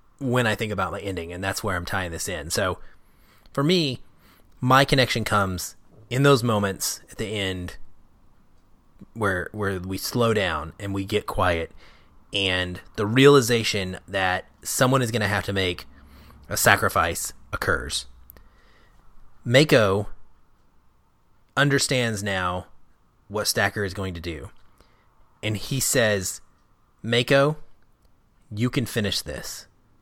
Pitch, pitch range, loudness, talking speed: 100 Hz, 90-115 Hz, -23 LUFS, 130 wpm